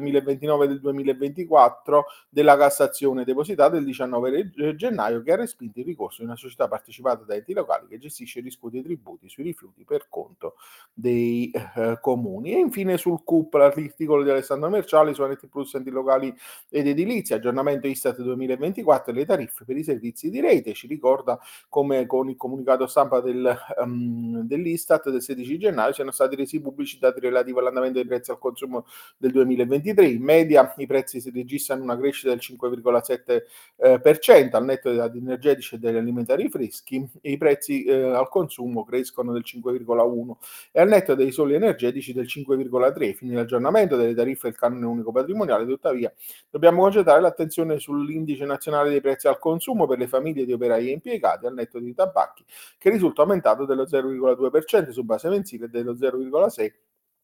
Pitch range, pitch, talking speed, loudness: 125-155 Hz, 135 Hz, 170 wpm, -22 LUFS